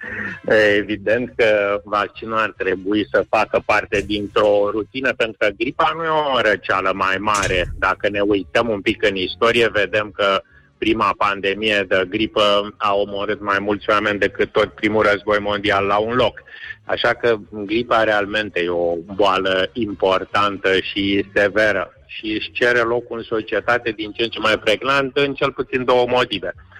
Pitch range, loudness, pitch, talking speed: 100-115 Hz, -18 LUFS, 105 Hz, 165 wpm